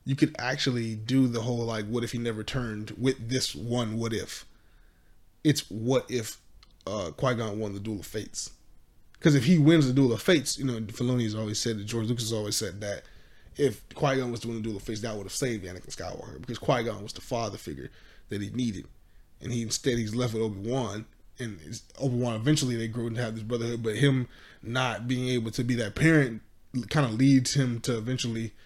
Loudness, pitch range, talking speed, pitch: -28 LUFS, 110-130 Hz, 225 wpm, 120 Hz